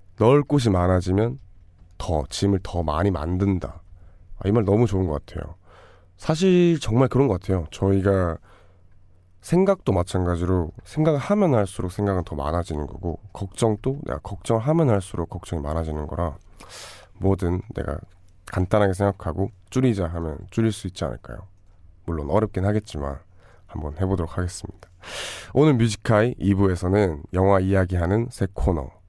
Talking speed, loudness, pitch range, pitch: 320 characters per minute, -23 LUFS, 85-105 Hz, 95 Hz